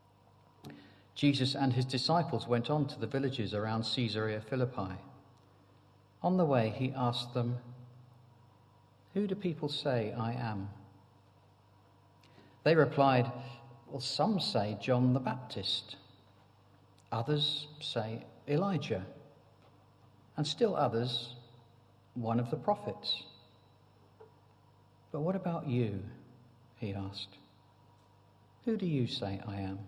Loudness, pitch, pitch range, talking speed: -34 LUFS, 120 Hz, 100-135 Hz, 110 wpm